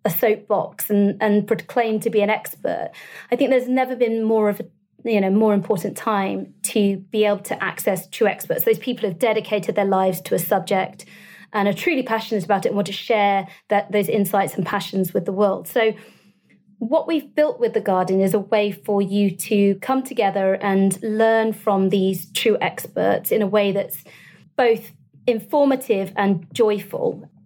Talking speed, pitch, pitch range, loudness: 185 wpm, 210 Hz, 195-225 Hz, -21 LUFS